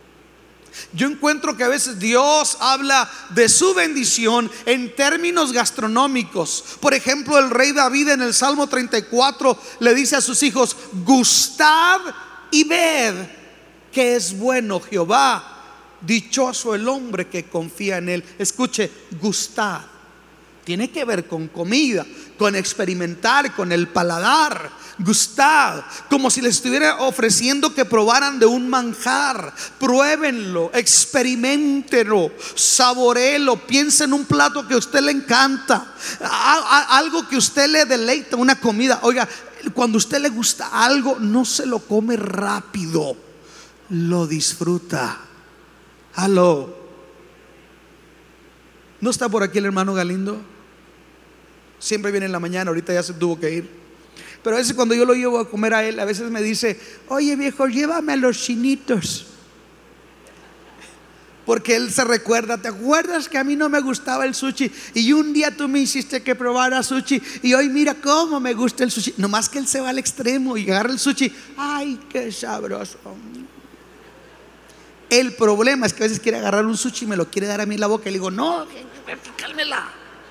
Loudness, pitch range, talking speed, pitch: -18 LUFS, 210-275 Hz, 155 wpm, 245 Hz